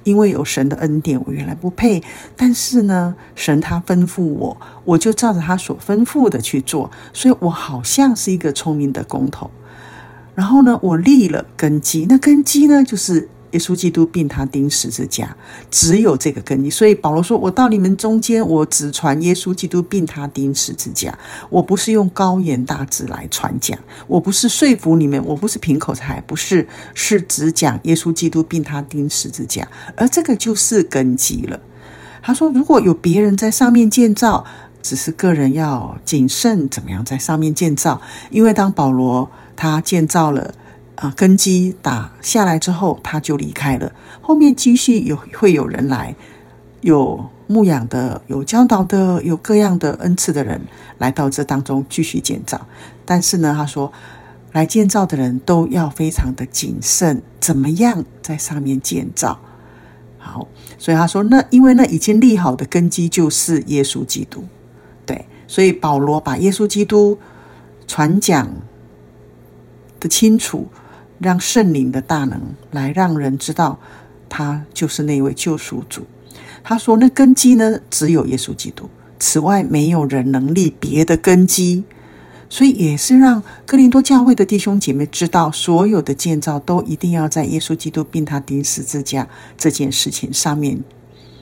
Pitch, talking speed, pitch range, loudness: 160 Hz, 245 characters per minute, 135-195 Hz, -15 LUFS